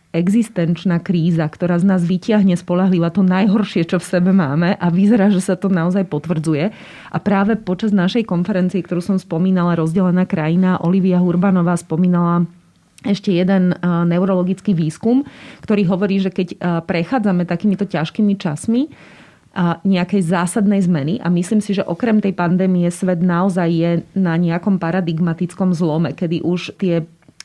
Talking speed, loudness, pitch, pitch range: 145 wpm, -17 LUFS, 180 Hz, 175-195 Hz